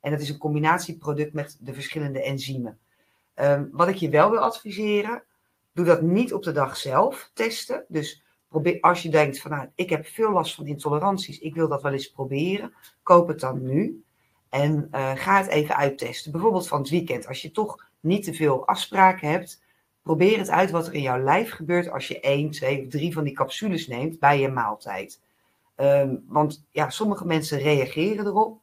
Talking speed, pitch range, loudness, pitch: 195 wpm, 140-175 Hz, -24 LUFS, 155 Hz